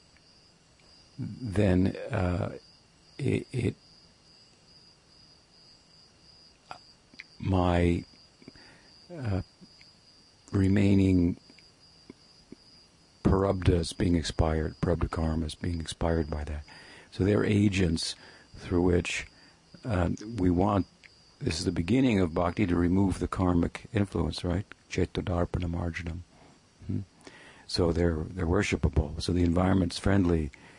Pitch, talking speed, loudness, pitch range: 90 Hz, 90 wpm, -28 LUFS, 85-100 Hz